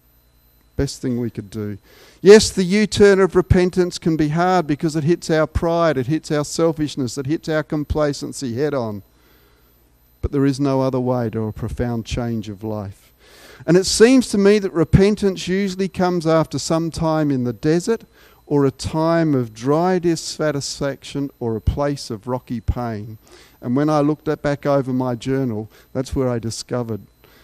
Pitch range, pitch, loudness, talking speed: 120-165 Hz, 140 Hz, -19 LUFS, 175 wpm